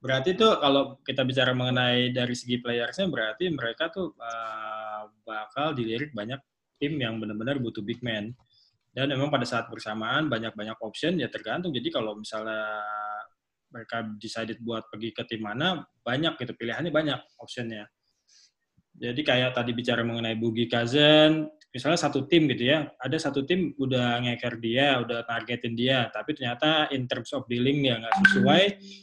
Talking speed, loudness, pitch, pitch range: 155 wpm, -27 LUFS, 120 Hz, 115-140 Hz